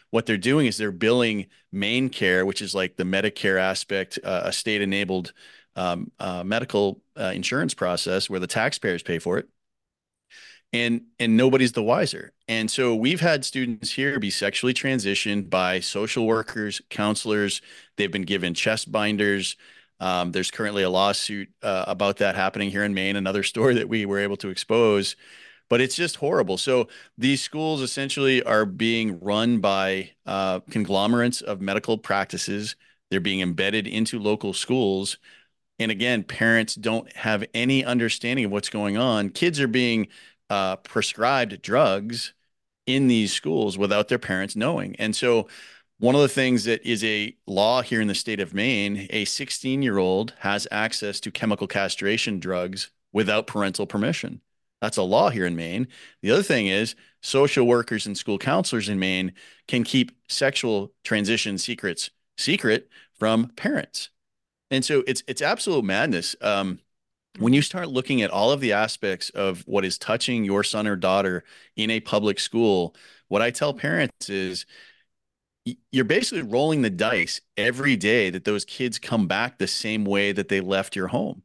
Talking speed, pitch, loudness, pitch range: 165 wpm, 105 Hz, -24 LUFS, 100-120 Hz